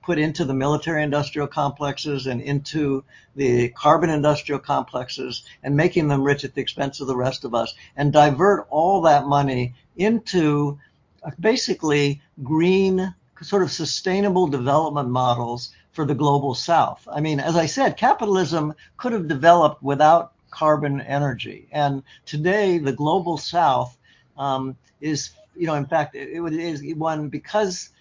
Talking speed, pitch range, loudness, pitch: 150 wpm, 140-170 Hz, -21 LUFS, 150 Hz